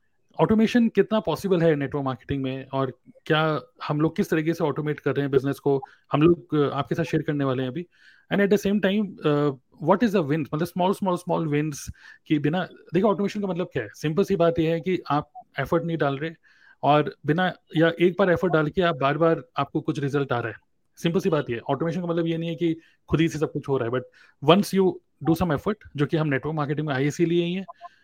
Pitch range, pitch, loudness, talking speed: 145-180 Hz, 160 Hz, -24 LUFS, 240 wpm